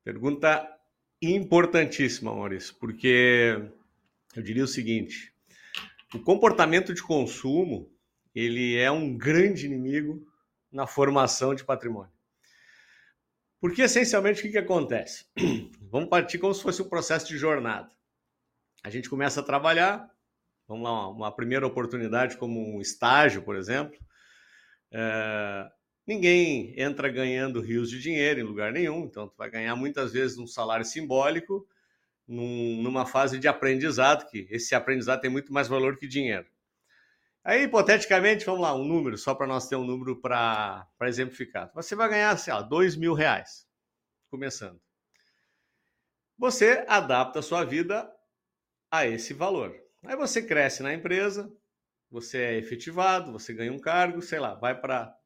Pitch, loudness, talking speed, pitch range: 135 Hz, -26 LUFS, 140 wpm, 120-170 Hz